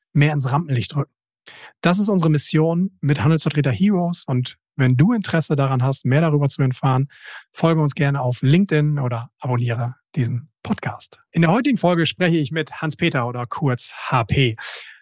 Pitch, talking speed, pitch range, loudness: 145 Hz, 165 wpm, 130-165 Hz, -20 LUFS